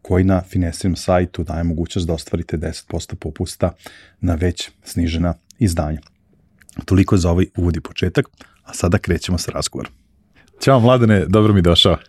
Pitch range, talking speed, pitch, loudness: 85-95 Hz, 150 wpm, 90 Hz, -18 LUFS